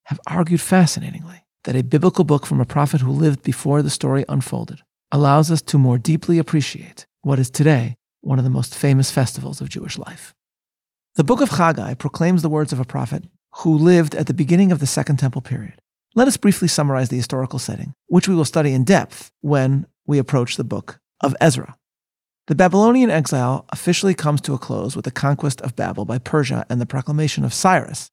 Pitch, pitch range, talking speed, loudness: 145 Hz, 135-165 Hz, 200 wpm, -18 LUFS